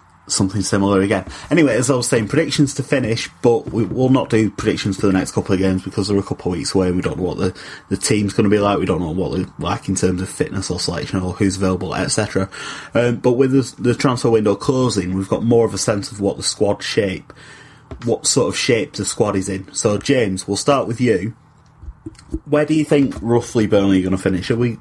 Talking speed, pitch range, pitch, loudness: 250 wpm, 95-125 Hz, 105 Hz, -18 LUFS